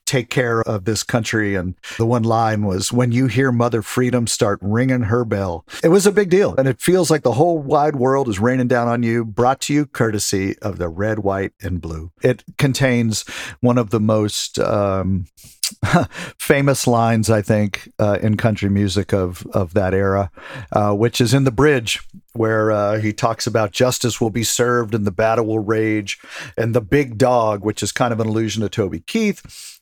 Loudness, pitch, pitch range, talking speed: -18 LUFS, 115 Hz, 105-125 Hz, 200 wpm